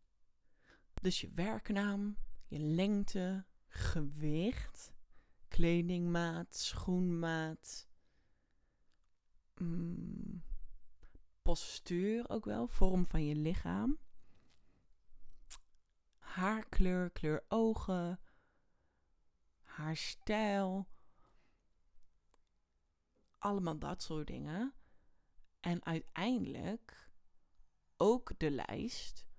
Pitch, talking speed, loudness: 170 Hz, 55 wpm, -39 LUFS